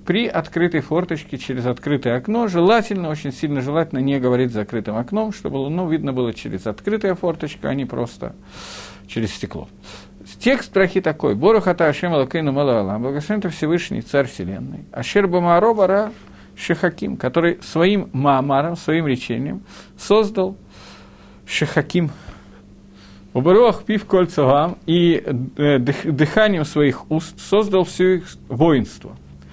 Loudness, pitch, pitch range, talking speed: -19 LUFS, 155 Hz, 125-180 Hz, 120 wpm